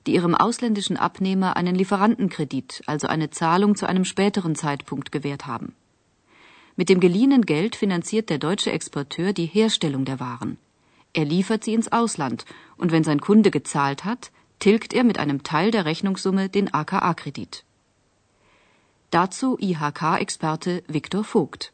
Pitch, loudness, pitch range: 185 Hz, -22 LUFS, 150-205 Hz